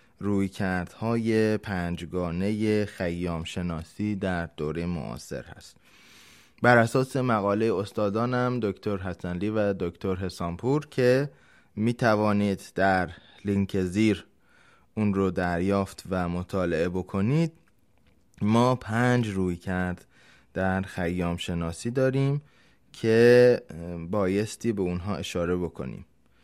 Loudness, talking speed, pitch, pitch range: -26 LUFS, 100 wpm, 100 Hz, 90-110 Hz